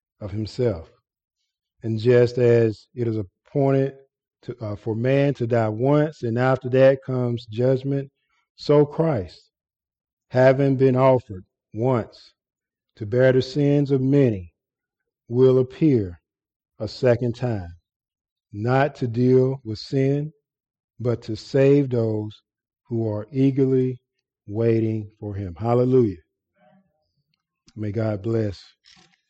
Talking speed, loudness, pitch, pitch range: 115 wpm, -21 LUFS, 125 Hz, 110-135 Hz